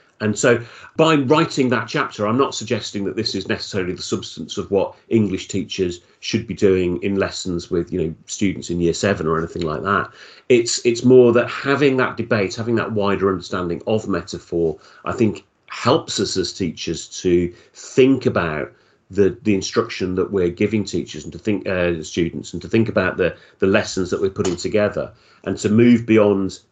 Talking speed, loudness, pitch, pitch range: 190 wpm, -20 LUFS, 105 Hz, 90-120 Hz